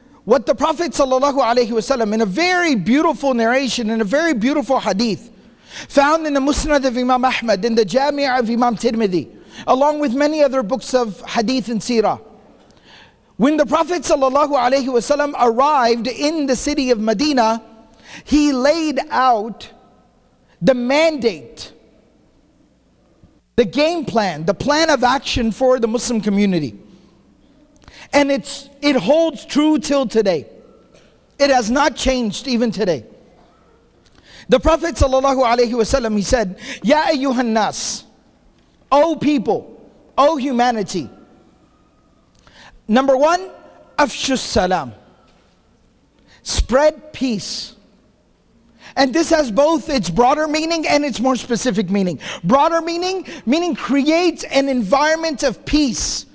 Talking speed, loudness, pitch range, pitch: 120 wpm, -17 LUFS, 230-290 Hz, 265 Hz